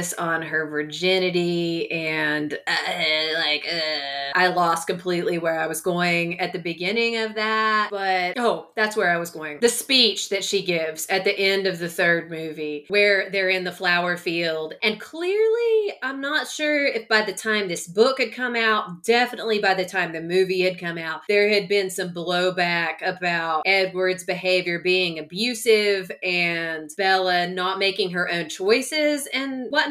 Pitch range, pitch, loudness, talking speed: 170-215 Hz, 185 Hz, -22 LUFS, 175 wpm